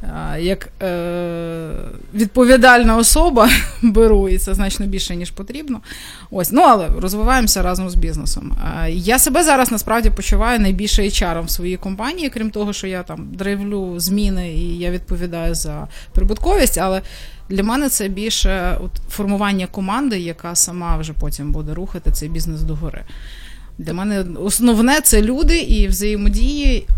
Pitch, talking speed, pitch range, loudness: 195 Hz, 145 wpm, 175-225 Hz, -17 LUFS